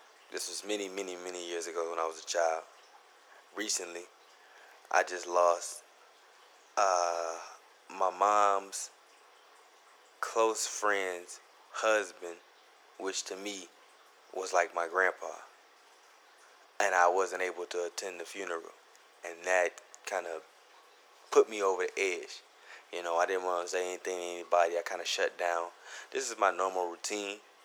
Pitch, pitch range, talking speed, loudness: 90 Hz, 85-100 Hz, 145 wpm, -32 LUFS